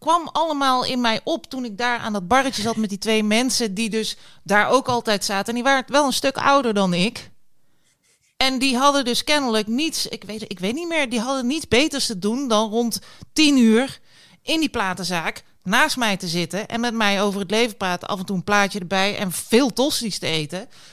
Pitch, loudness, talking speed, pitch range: 230 Hz, -20 LUFS, 225 wpm, 205-260 Hz